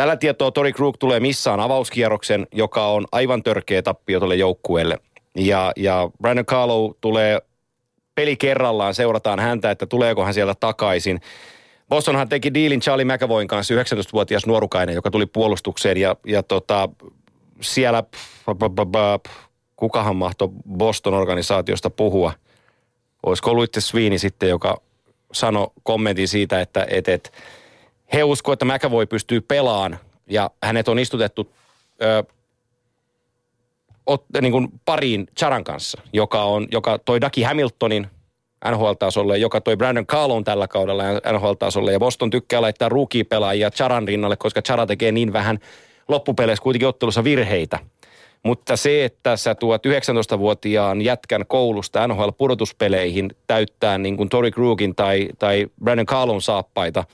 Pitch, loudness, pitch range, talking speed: 115 Hz, -20 LUFS, 105-125 Hz, 130 wpm